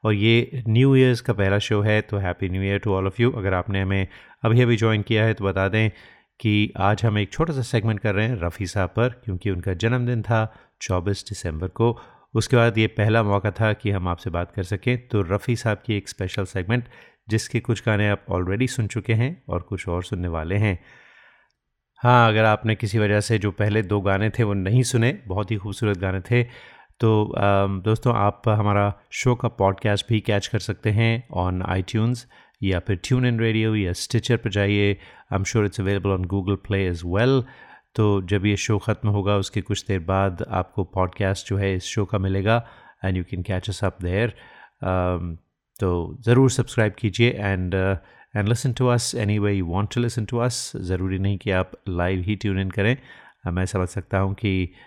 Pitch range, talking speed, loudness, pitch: 95-115 Hz, 205 wpm, -23 LUFS, 105 Hz